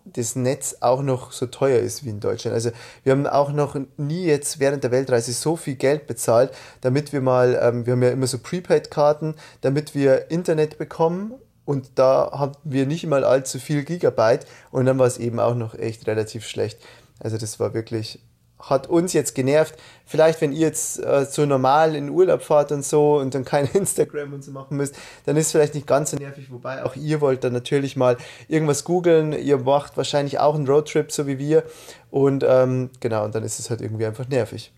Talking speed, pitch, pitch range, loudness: 210 wpm, 140 Hz, 125-150 Hz, -21 LUFS